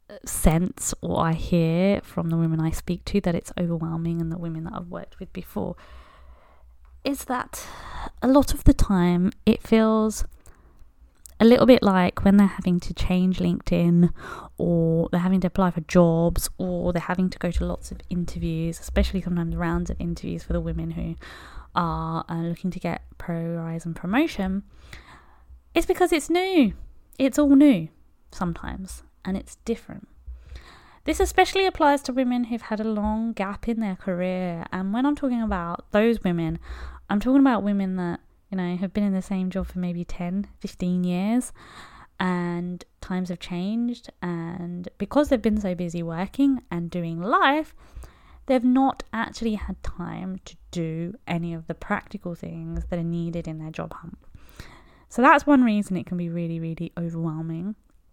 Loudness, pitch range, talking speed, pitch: -24 LUFS, 170-215 Hz, 170 wpm, 180 Hz